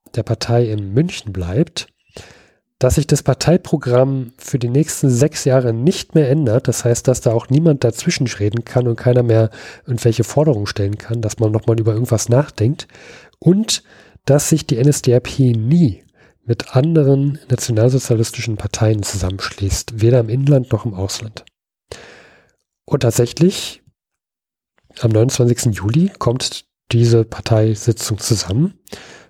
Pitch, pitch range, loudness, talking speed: 120 Hz, 110-140 Hz, -16 LUFS, 135 wpm